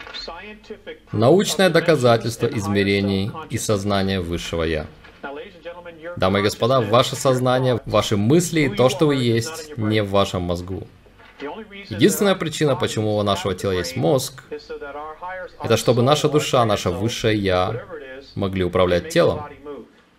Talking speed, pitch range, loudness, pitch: 120 wpm, 100-150 Hz, -20 LUFS, 115 Hz